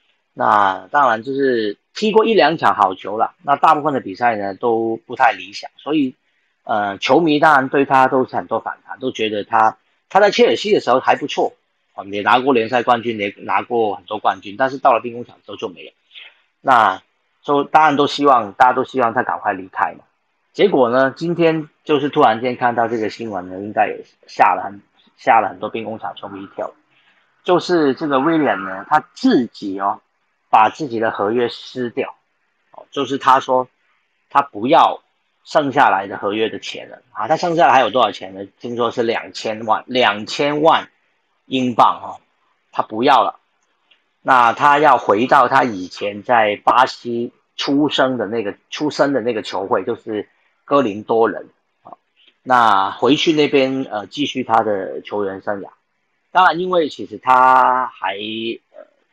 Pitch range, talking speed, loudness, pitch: 110-145 Hz, 255 characters per minute, -17 LUFS, 130 Hz